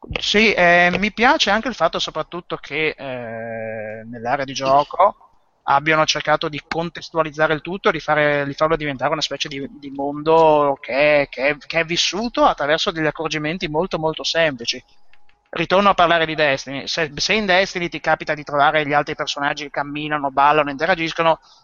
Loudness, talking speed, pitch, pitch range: -18 LUFS, 170 wpm, 155 Hz, 145-170 Hz